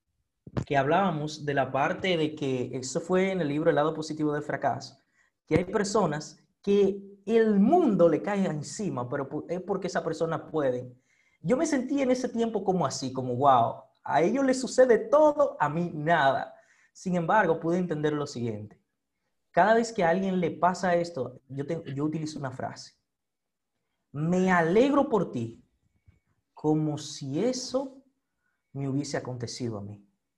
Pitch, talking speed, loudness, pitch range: 165 Hz, 160 wpm, -27 LUFS, 140-200 Hz